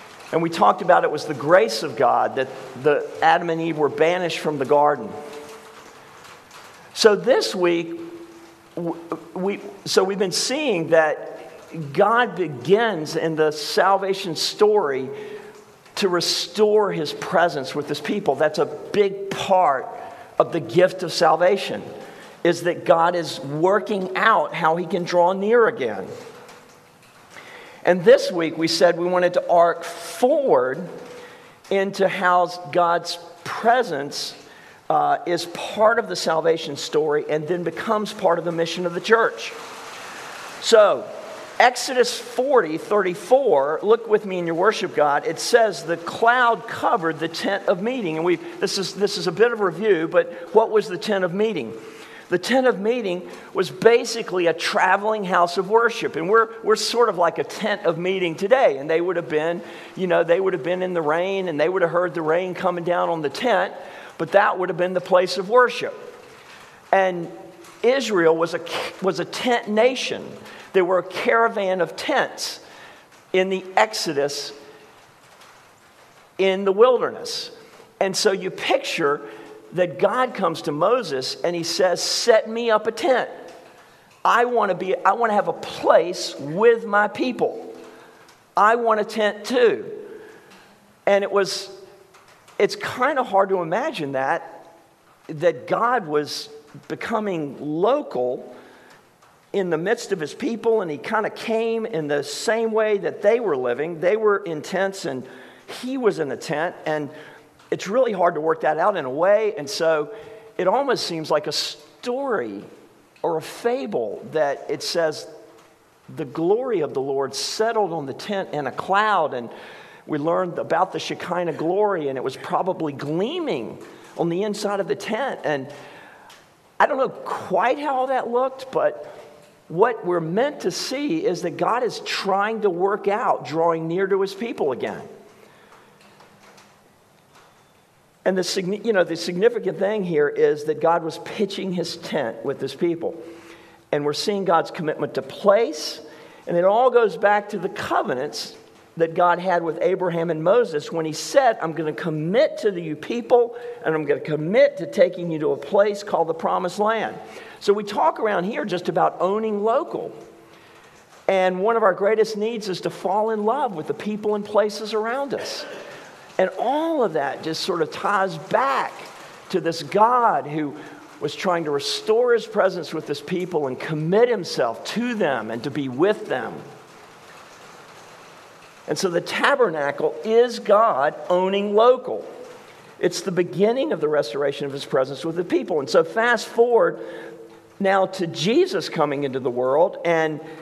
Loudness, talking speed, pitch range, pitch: -21 LUFS, 165 wpm, 165-225 Hz, 185 Hz